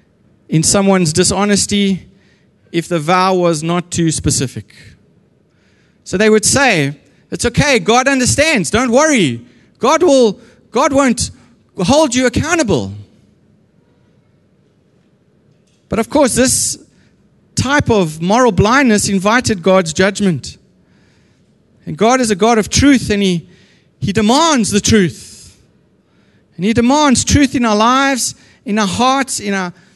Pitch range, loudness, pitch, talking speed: 180-250 Hz, -13 LUFS, 205 Hz, 125 wpm